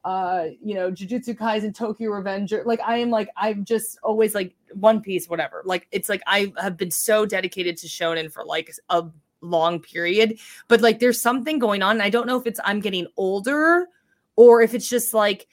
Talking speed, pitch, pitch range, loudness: 205 wpm, 210 Hz, 185-230 Hz, -21 LUFS